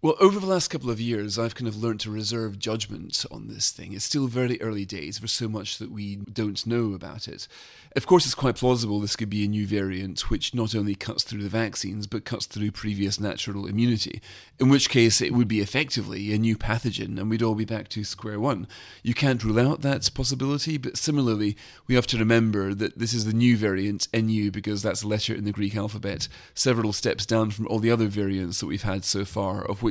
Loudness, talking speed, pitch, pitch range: -25 LUFS, 235 wpm, 110 Hz, 105-120 Hz